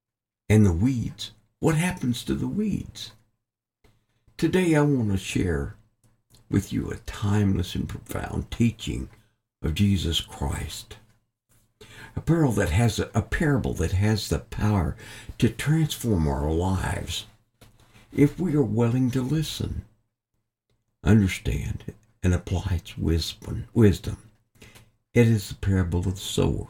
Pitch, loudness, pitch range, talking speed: 110 Hz, -25 LUFS, 100-115 Hz, 125 wpm